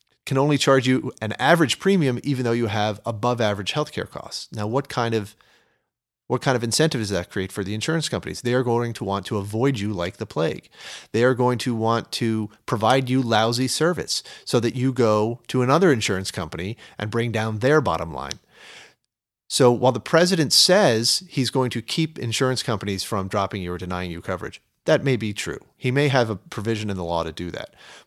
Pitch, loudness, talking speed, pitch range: 115 Hz, -22 LUFS, 210 wpm, 105-130 Hz